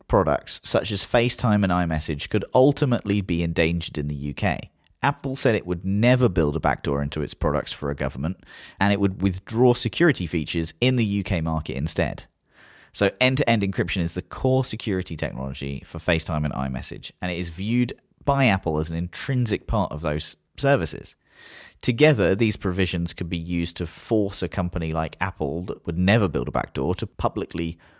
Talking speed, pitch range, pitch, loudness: 180 wpm, 80-110 Hz, 90 Hz, -24 LUFS